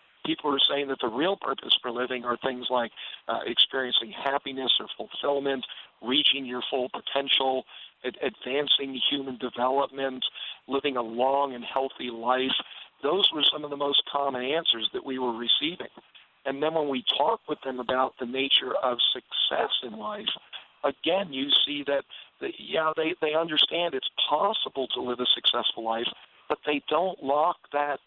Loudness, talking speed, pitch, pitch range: -26 LUFS, 165 wpm, 135 Hz, 125-145 Hz